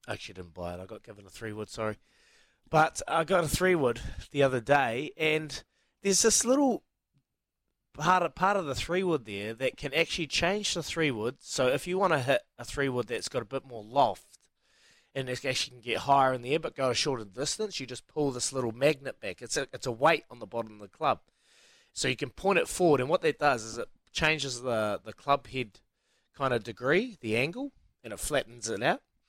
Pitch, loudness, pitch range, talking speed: 135 Hz, -29 LUFS, 115-165 Hz, 235 wpm